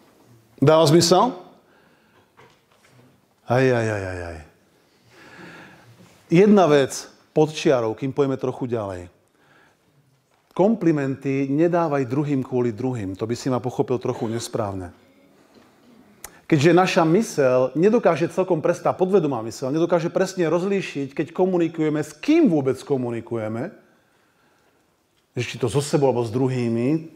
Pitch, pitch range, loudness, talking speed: 140 Hz, 120-170 Hz, -21 LUFS, 110 wpm